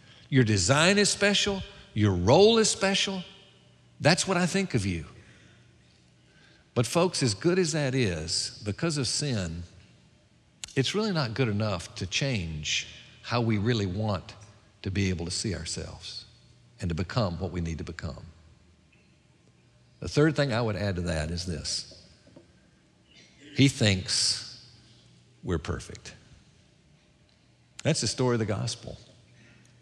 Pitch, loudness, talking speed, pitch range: 110 Hz, -27 LUFS, 140 wpm, 90-135 Hz